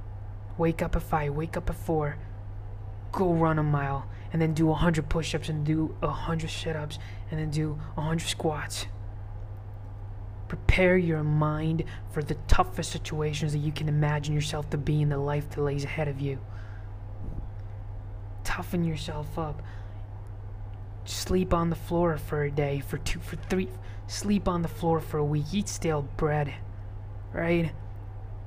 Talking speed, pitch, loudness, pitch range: 160 wpm, 140 Hz, -29 LUFS, 100-155 Hz